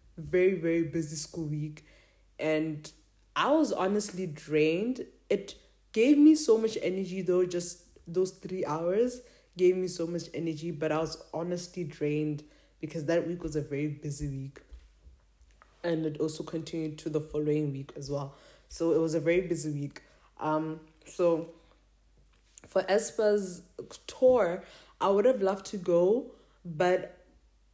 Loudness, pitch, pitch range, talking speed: -30 LUFS, 165 Hz, 155-185 Hz, 145 wpm